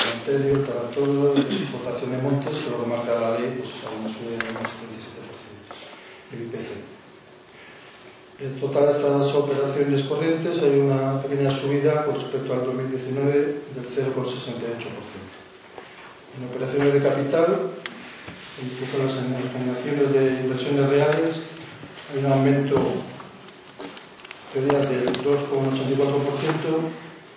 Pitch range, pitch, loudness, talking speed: 130-140 Hz, 140 Hz, -24 LUFS, 110 wpm